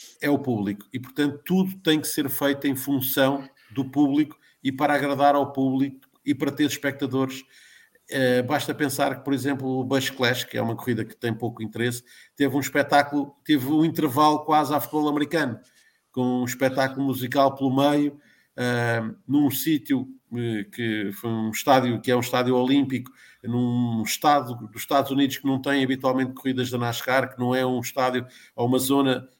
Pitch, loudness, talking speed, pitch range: 135 Hz, -24 LUFS, 180 wpm, 125-145 Hz